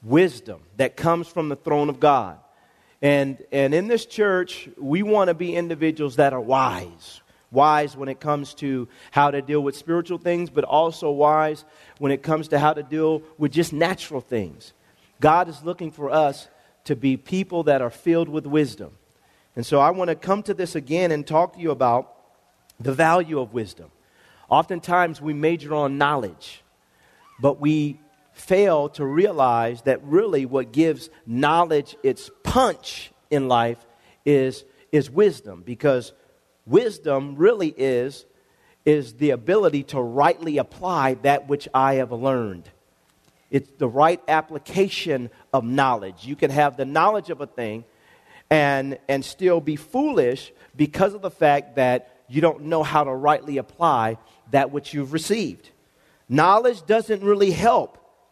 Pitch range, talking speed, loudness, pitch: 135-170 Hz, 155 wpm, -22 LUFS, 150 Hz